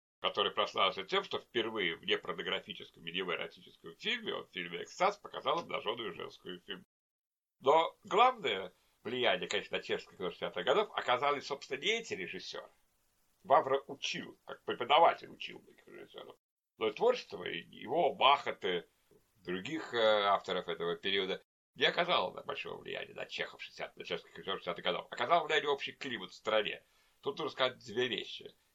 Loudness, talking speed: -34 LUFS, 155 wpm